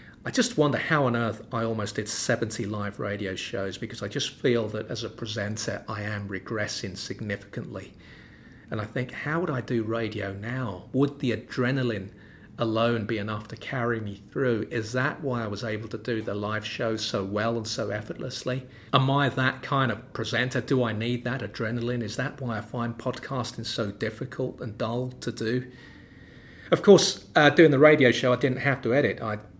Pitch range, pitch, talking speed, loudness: 110-130 Hz, 115 Hz, 195 wpm, -27 LUFS